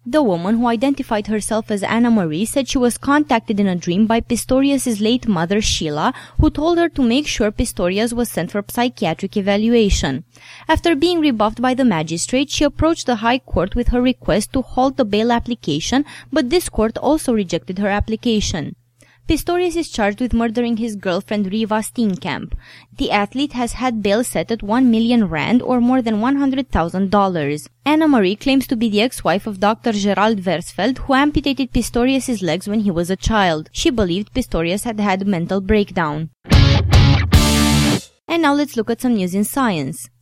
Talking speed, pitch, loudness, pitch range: 180 wpm, 225 Hz, -18 LUFS, 195-255 Hz